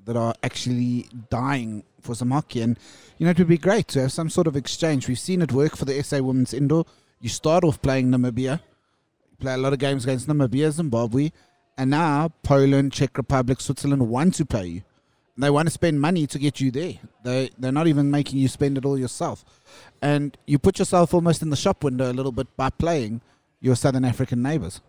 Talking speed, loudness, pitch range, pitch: 210 wpm, -23 LUFS, 125-150 Hz, 140 Hz